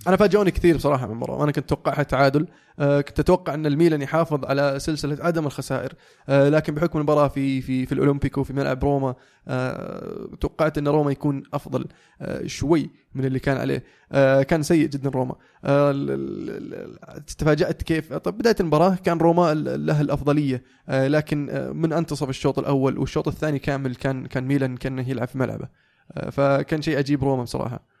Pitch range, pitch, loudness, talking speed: 135-155 Hz, 145 Hz, -22 LUFS, 155 wpm